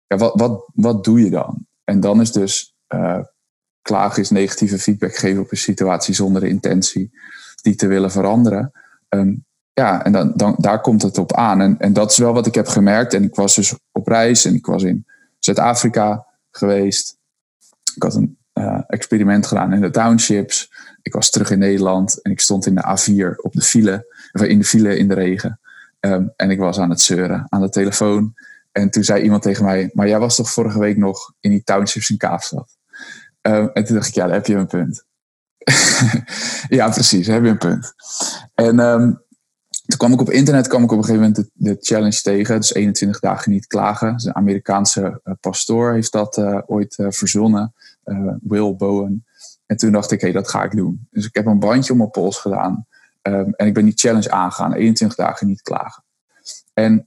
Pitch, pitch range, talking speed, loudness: 105 Hz, 100-110 Hz, 210 wpm, -16 LUFS